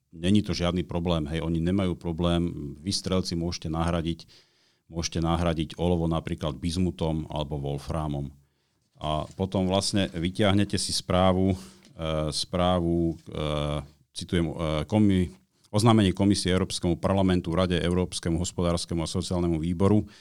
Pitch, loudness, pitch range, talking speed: 85 Hz, -27 LUFS, 80-95 Hz, 115 wpm